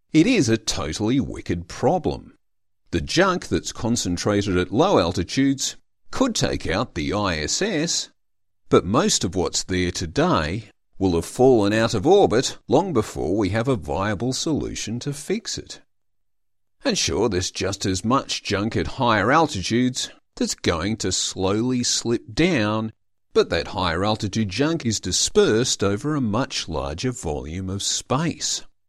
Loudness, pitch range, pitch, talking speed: -22 LUFS, 95-120 Hz, 105 Hz, 145 wpm